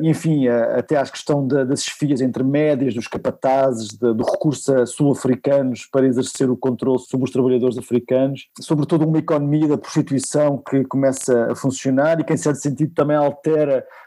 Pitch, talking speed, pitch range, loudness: 135 Hz, 165 wpm, 130-150 Hz, -19 LUFS